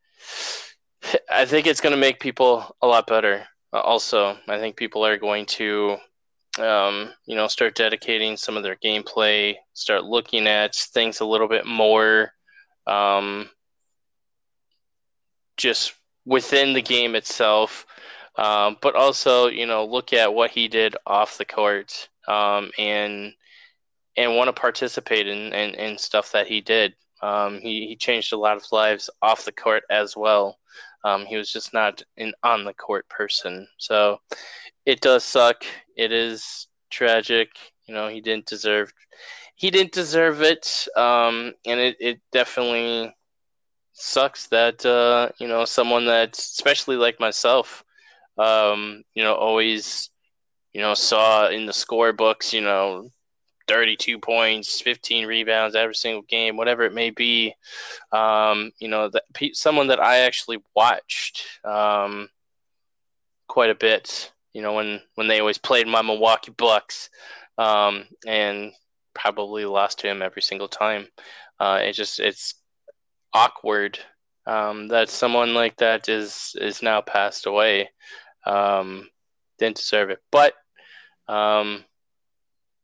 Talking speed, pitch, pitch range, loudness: 145 wpm, 110 Hz, 105-115 Hz, -21 LUFS